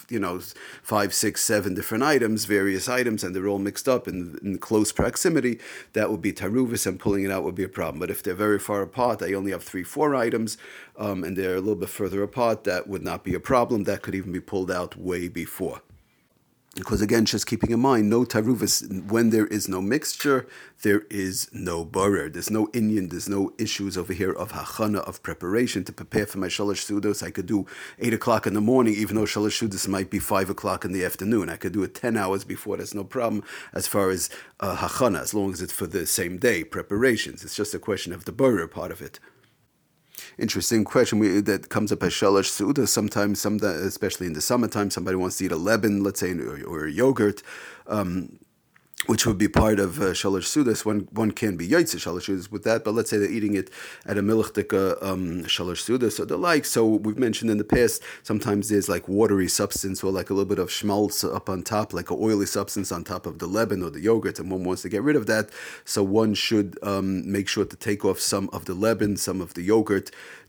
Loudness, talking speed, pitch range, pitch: -25 LUFS, 225 wpm, 95-110 Hz, 100 Hz